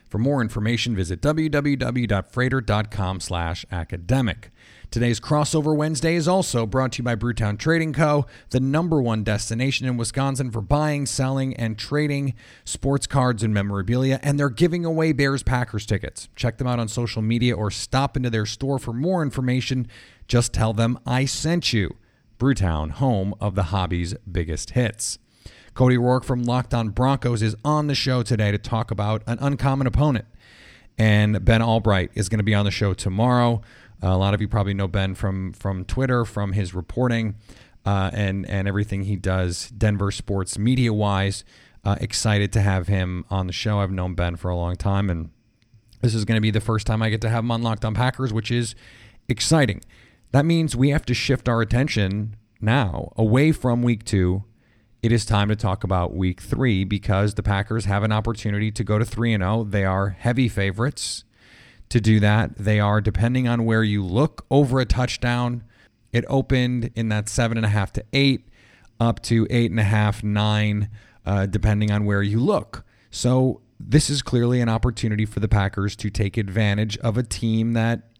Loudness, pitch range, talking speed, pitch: -22 LUFS, 105-125 Hz, 180 wpm, 115 Hz